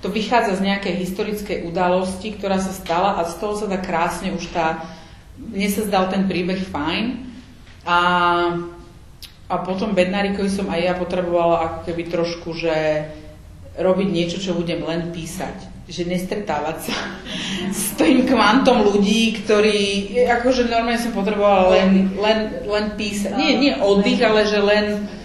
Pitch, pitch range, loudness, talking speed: 190 Hz, 175-210 Hz, -19 LUFS, 150 wpm